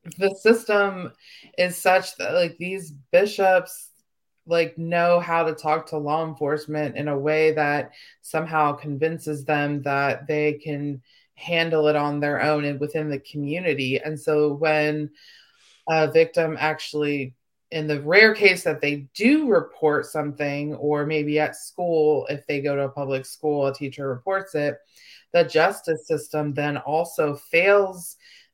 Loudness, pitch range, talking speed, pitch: -22 LUFS, 145-165 Hz, 150 wpm, 155 Hz